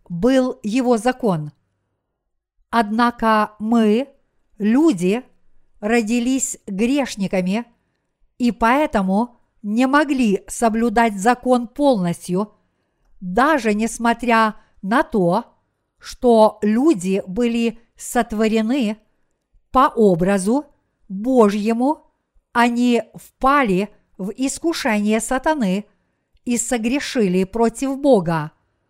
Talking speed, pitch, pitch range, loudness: 75 wpm, 230 Hz, 205-250 Hz, -19 LUFS